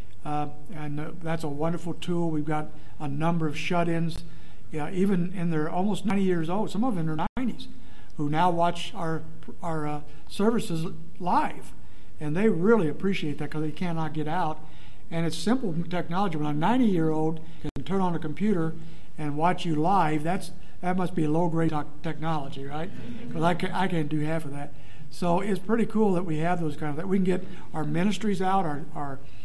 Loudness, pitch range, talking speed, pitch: -28 LUFS, 150-180 Hz, 200 wpm, 165 Hz